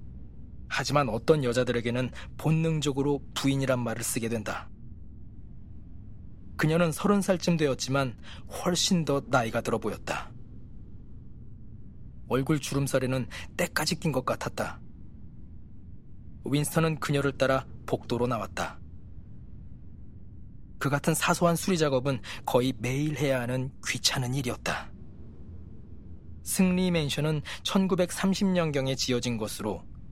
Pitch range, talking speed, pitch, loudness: 110-150 Hz, 235 characters per minute, 130 Hz, -28 LUFS